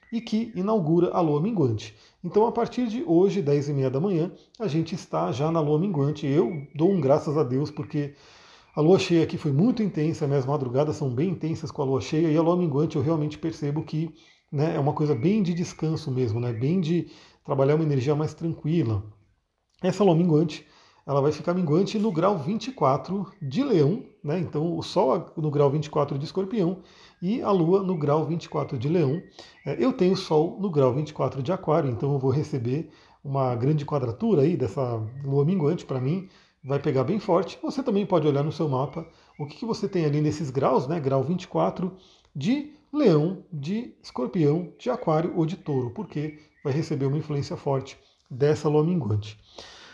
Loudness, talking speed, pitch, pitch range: -25 LUFS, 190 wpm, 155 Hz, 145-180 Hz